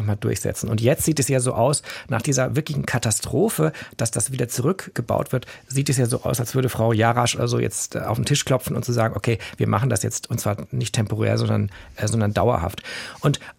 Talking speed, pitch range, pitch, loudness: 225 wpm, 110-130 Hz, 120 Hz, -22 LUFS